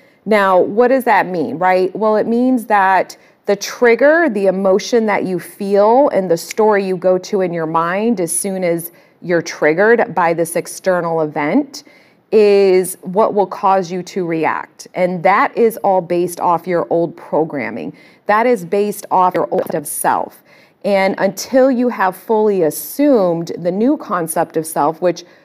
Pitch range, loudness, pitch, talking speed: 175-220 Hz, -15 LUFS, 190 Hz, 165 wpm